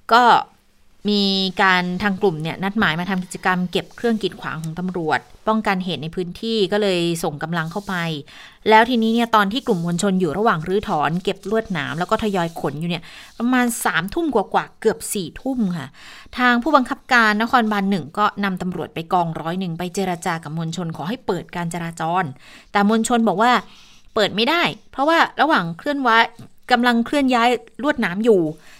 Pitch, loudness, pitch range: 195 Hz, -20 LUFS, 175-225 Hz